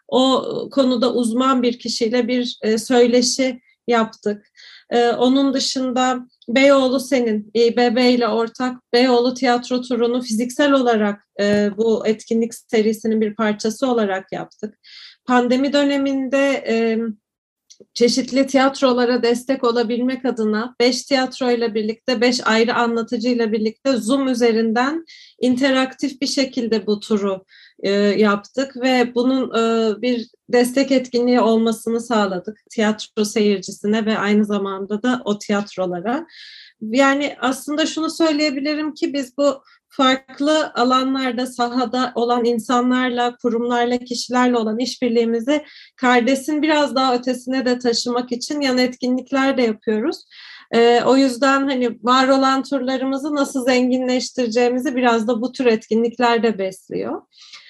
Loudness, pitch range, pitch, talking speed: -18 LUFS, 230-265 Hz, 245 Hz, 115 wpm